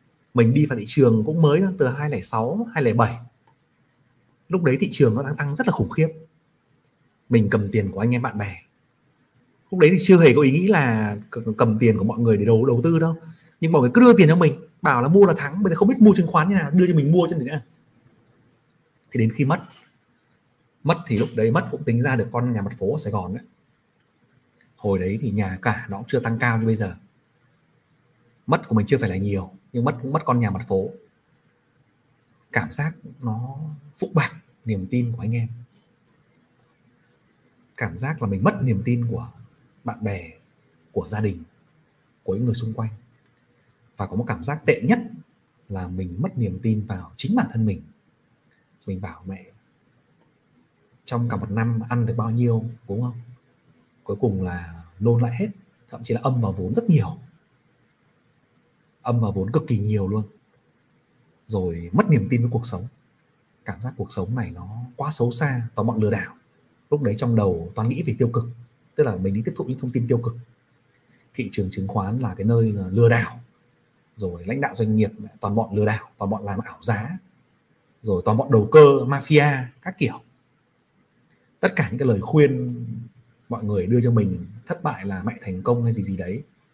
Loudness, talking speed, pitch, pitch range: -21 LUFS, 205 wpm, 120 Hz, 110-145 Hz